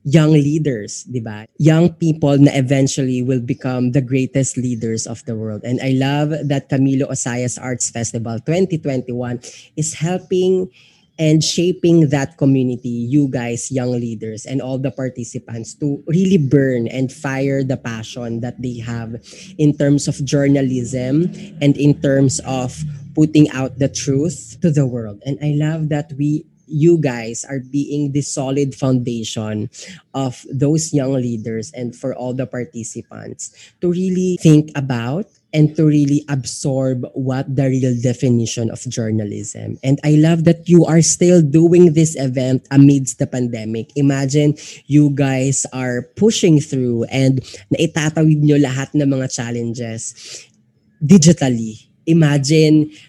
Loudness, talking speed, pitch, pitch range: -17 LUFS, 140 wpm, 135 Hz, 125-150 Hz